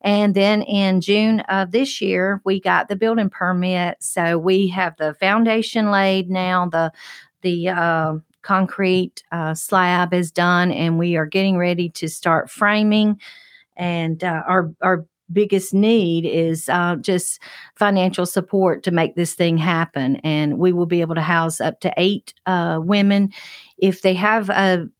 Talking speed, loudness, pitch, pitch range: 160 wpm, -19 LUFS, 185 Hz, 170-200 Hz